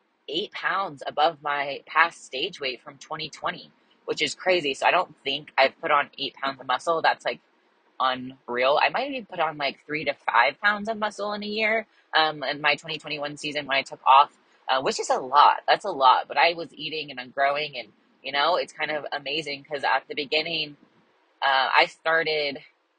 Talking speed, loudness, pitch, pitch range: 205 wpm, -24 LUFS, 150 Hz, 140-165 Hz